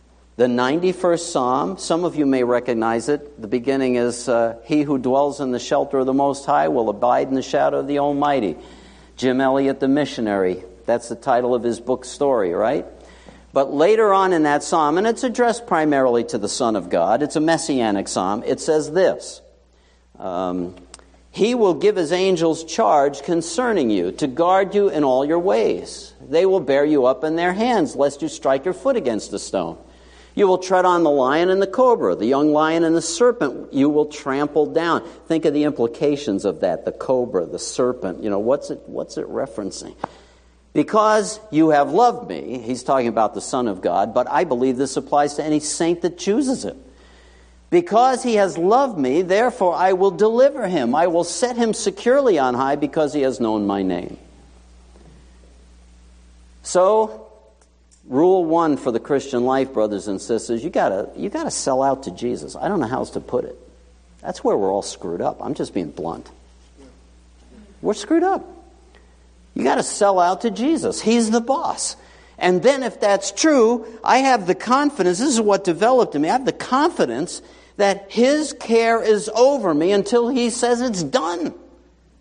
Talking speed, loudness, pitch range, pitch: 190 wpm, -19 LUFS, 120-195 Hz, 145 Hz